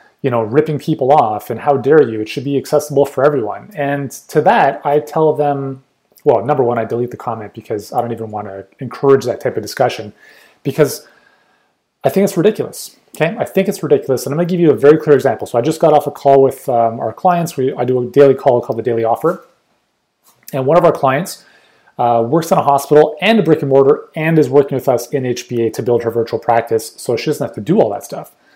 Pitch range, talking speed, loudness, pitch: 120-150 Hz, 245 wpm, -14 LUFS, 140 Hz